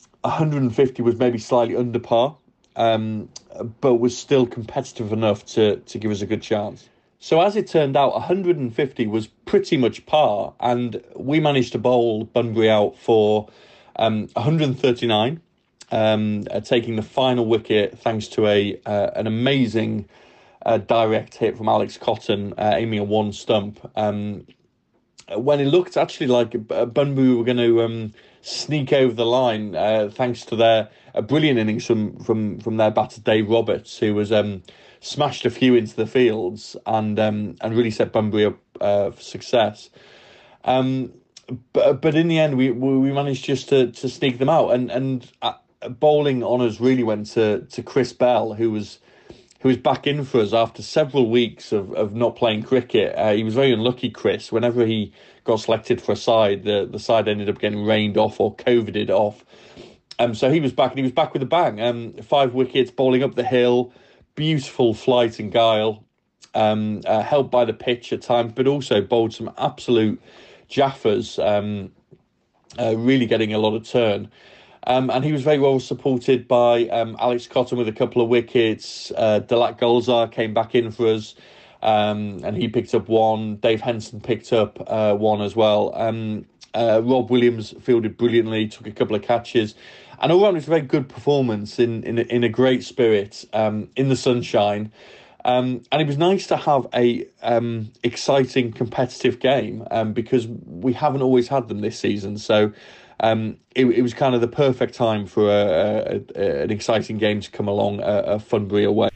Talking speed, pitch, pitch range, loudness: 185 wpm, 120 Hz, 110-130 Hz, -20 LUFS